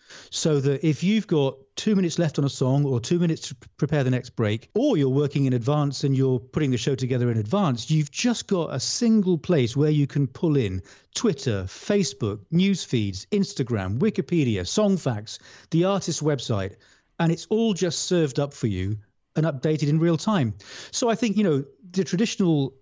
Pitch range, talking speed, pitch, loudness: 130-180 Hz, 195 wpm, 145 Hz, -24 LUFS